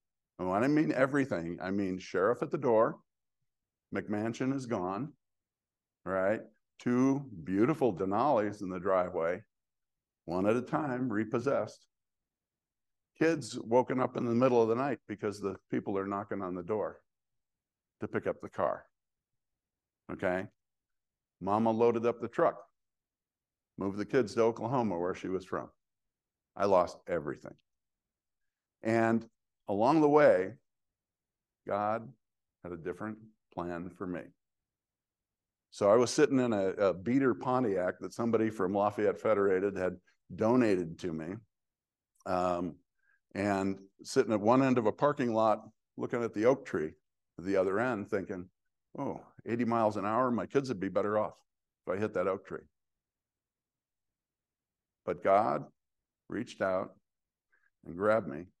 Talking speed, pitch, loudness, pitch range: 140 wpm, 105 Hz, -32 LUFS, 95-120 Hz